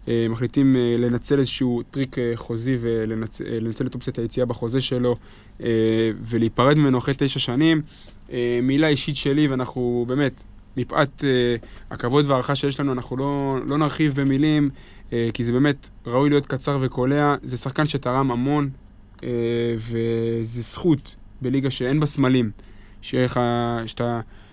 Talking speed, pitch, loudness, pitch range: 120 wpm, 125 Hz, -22 LUFS, 115-140 Hz